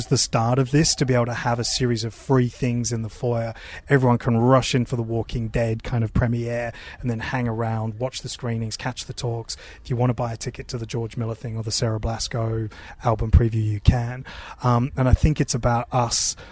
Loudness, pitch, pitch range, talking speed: -23 LUFS, 120 Hz, 115-125 Hz, 235 wpm